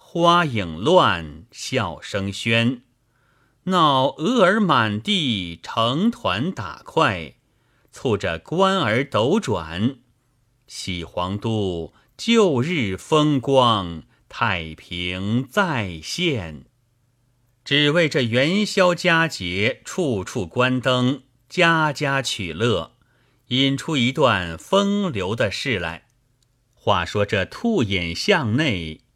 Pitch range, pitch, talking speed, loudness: 100-145 Hz, 125 Hz, 130 characters per minute, -21 LUFS